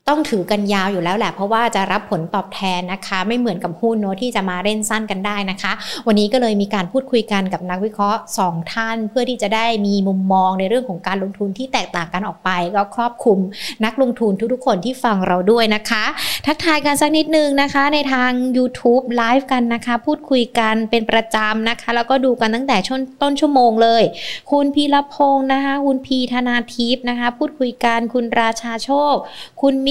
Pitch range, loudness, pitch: 205-260 Hz, -17 LUFS, 230 Hz